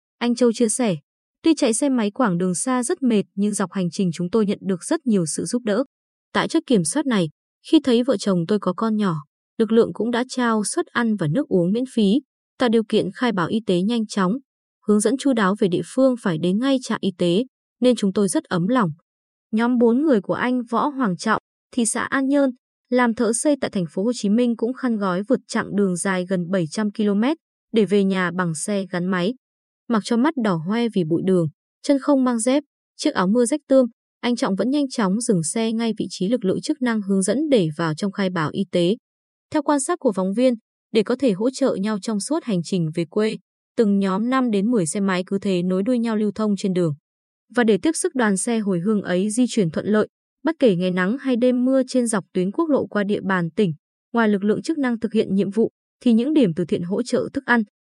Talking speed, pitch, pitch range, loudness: 245 wpm, 220 Hz, 190-250 Hz, -21 LUFS